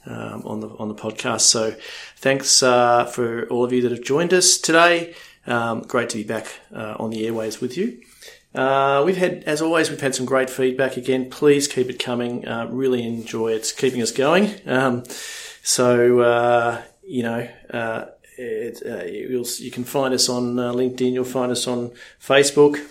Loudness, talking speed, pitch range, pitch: -20 LUFS, 185 wpm, 120-135 Hz, 125 Hz